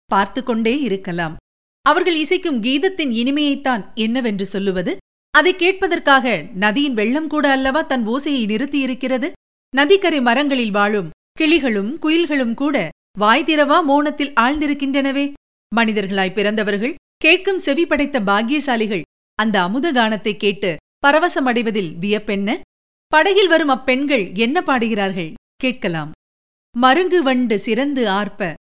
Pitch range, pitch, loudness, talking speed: 210-295 Hz, 255 Hz, -17 LUFS, 105 wpm